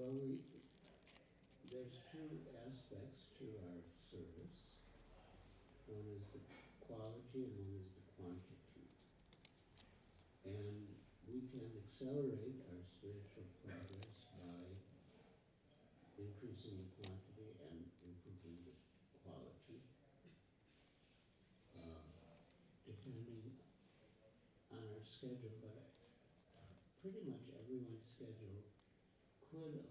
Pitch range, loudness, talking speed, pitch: 95-125 Hz, -55 LUFS, 85 wpm, 105 Hz